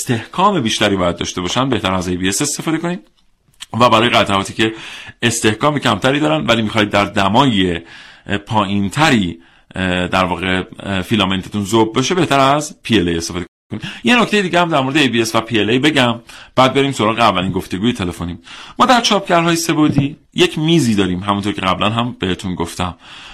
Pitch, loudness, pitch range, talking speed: 110 Hz, -15 LUFS, 95-140 Hz, 155 wpm